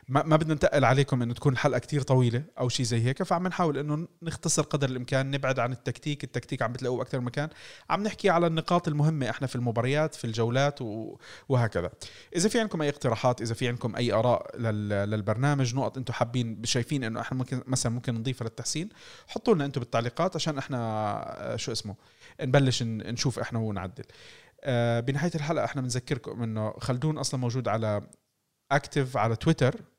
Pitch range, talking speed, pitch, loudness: 120-145 Hz, 170 wpm, 130 Hz, -28 LUFS